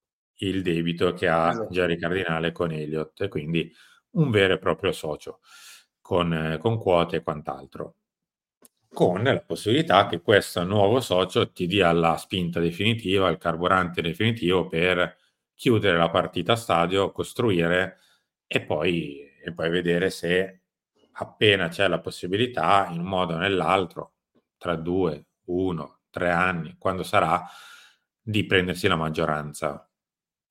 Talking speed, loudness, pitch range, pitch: 135 wpm, -24 LUFS, 85-95 Hz, 90 Hz